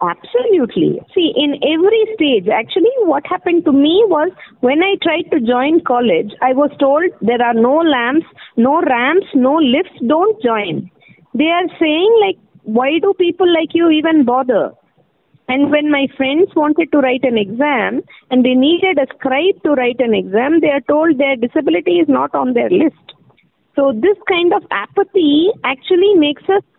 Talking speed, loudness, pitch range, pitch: 170 wpm, -14 LUFS, 265-355 Hz, 305 Hz